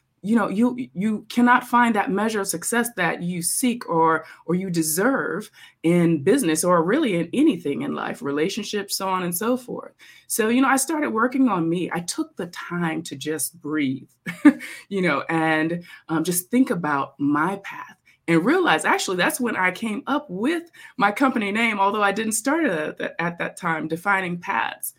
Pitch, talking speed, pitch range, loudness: 195 Hz, 180 wpm, 165-240 Hz, -22 LUFS